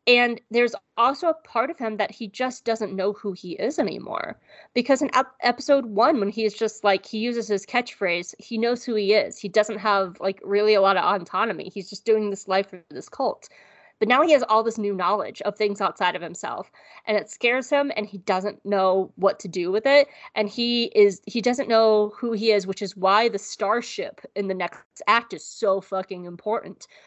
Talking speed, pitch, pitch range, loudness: 215 wpm, 210 Hz, 195-240 Hz, -23 LUFS